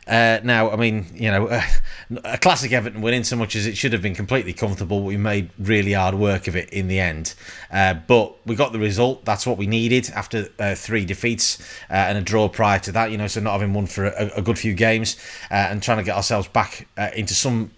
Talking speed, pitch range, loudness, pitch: 250 wpm, 100-115 Hz, -21 LUFS, 105 Hz